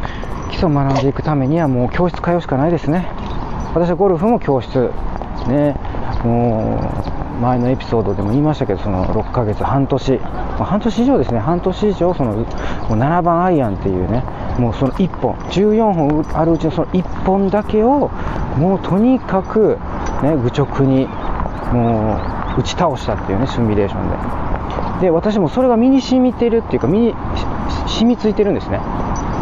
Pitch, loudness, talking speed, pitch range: 140 Hz, -17 LUFS, 330 characters per minute, 115-185 Hz